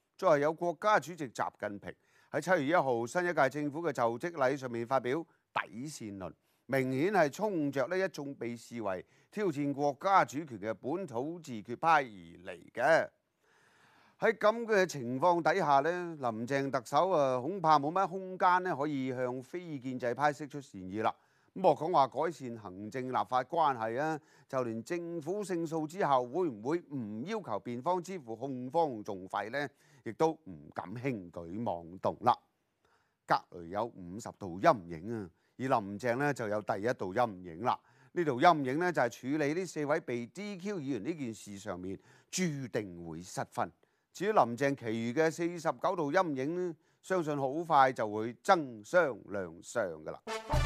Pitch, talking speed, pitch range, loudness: 140 Hz, 245 characters per minute, 115-170 Hz, -33 LUFS